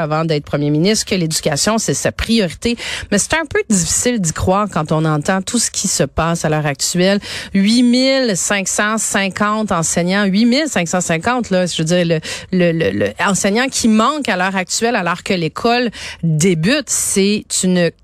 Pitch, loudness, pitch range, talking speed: 195 Hz, -15 LUFS, 170-225 Hz, 175 wpm